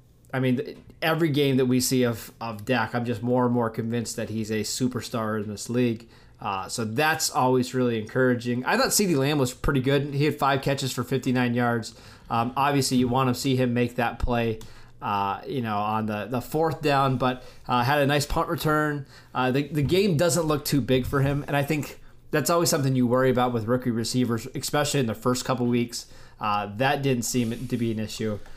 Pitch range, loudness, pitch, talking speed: 120-140 Hz, -25 LUFS, 125 Hz, 220 wpm